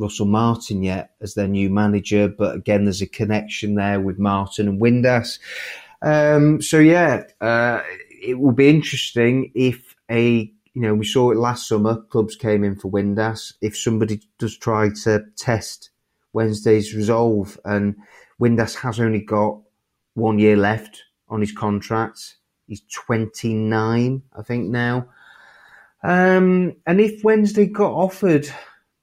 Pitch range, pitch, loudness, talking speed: 105-125 Hz, 110 Hz, -19 LUFS, 145 wpm